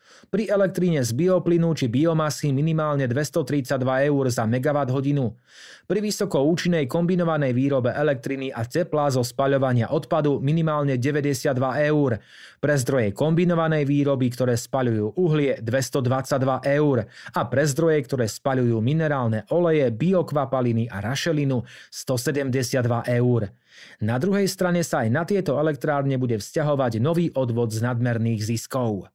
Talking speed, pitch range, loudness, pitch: 125 wpm, 125-155 Hz, -23 LUFS, 140 Hz